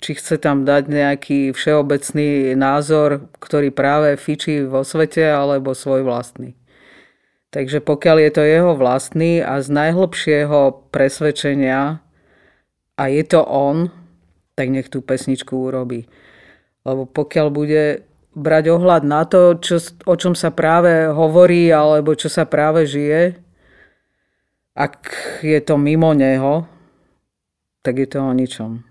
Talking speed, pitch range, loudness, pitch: 130 wpm, 135-160 Hz, -16 LUFS, 150 Hz